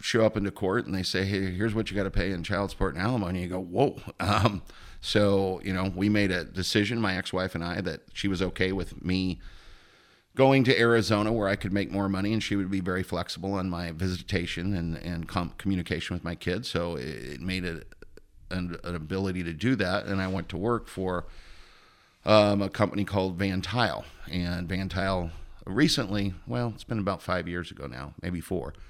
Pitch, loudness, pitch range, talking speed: 95 Hz, -28 LUFS, 90-100 Hz, 215 wpm